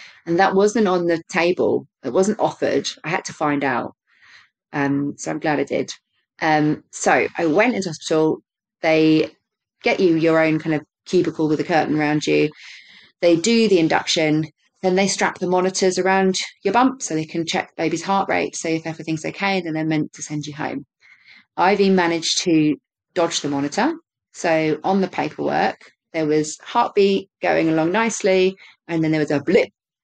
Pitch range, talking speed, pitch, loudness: 155-190 Hz, 185 wpm, 165 Hz, -20 LUFS